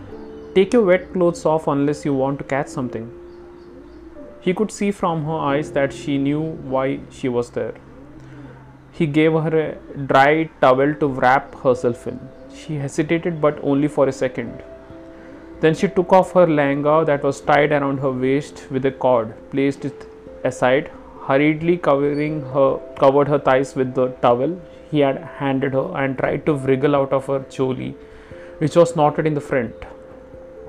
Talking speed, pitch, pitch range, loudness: 170 wpm, 140 Hz, 135-160 Hz, -19 LUFS